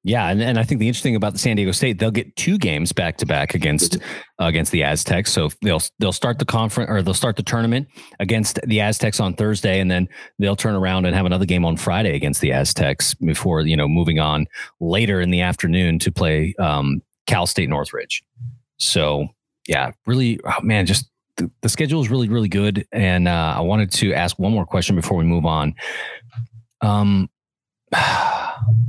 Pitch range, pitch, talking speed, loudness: 90-115 Hz, 100 Hz, 200 wpm, -19 LUFS